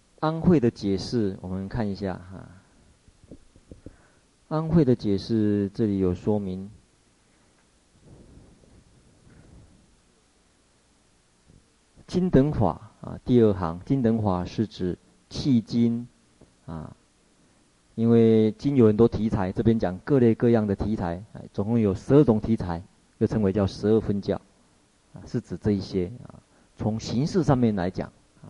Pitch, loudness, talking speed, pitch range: 105 Hz, -24 LUFS, 180 characters per minute, 90-115 Hz